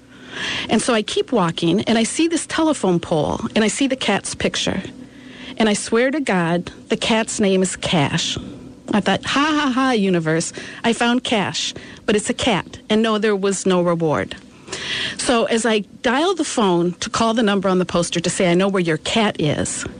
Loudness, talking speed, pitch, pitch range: -19 LUFS, 200 wpm, 215 Hz, 180-245 Hz